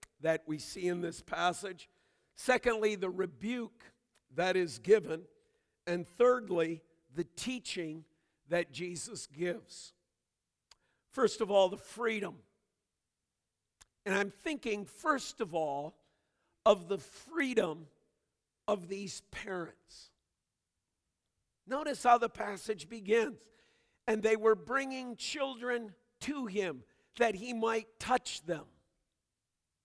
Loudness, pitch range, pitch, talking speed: -34 LUFS, 165-235 Hz, 200 Hz, 105 wpm